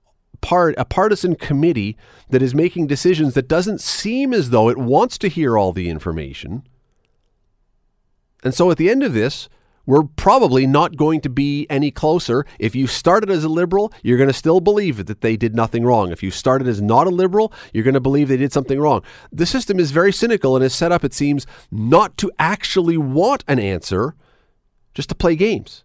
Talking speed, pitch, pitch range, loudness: 200 wpm, 140 Hz, 120-175 Hz, -17 LUFS